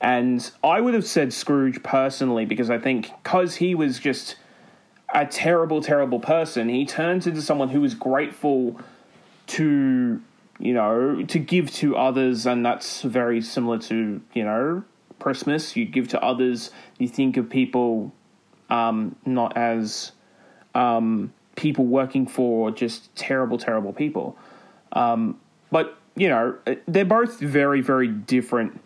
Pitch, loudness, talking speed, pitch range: 135 Hz, -23 LUFS, 140 wpm, 120-170 Hz